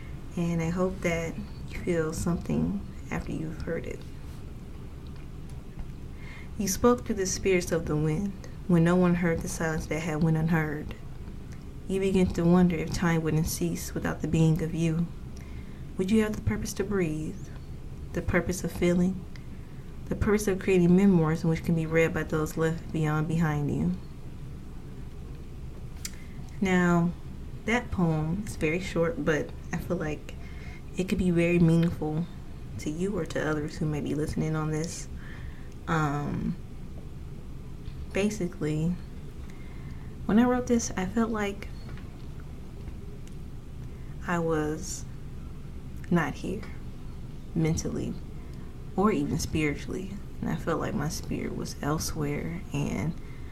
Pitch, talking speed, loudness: 160 Hz, 135 wpm, -28 LUFS